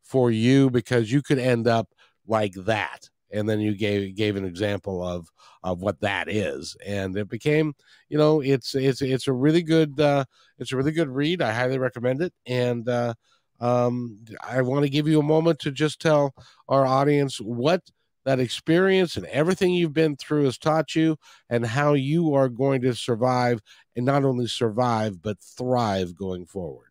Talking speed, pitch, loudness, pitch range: 185 wpm, 130 Hz, -24 LUFS, 115-145 Hz